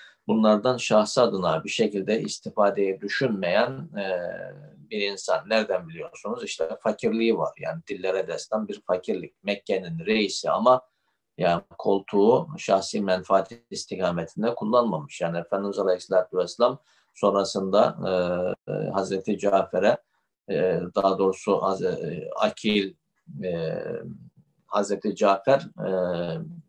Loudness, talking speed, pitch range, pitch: -25 LUFS, 90 wpm, 95-110 Hz, 100 Hz